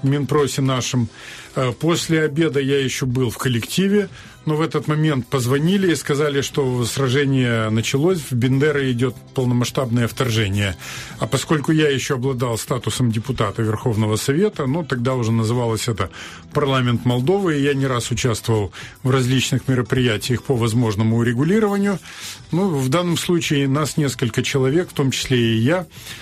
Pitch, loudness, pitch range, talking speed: 130 Hz, -19 LUFS, 120-150 Hz, 145 wpm